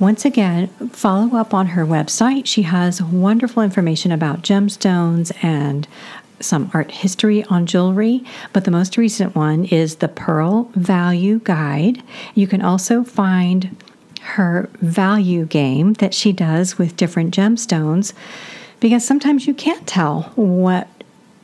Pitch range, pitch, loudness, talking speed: 175-220 Hz, 195 Hz, -17 LUFS, 135 wpm